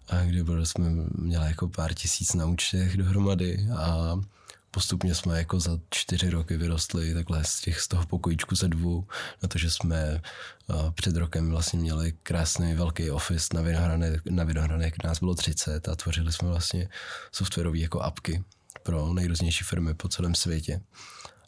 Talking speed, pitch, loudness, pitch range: 155 wpm, 85 Hz, -28 LUFS, 80-90 Hz